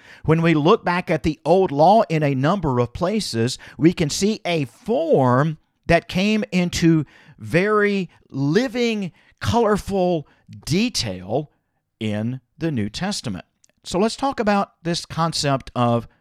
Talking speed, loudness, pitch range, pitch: 135 wpm, -20 LUFS, 130-195 Hz, 165 Hz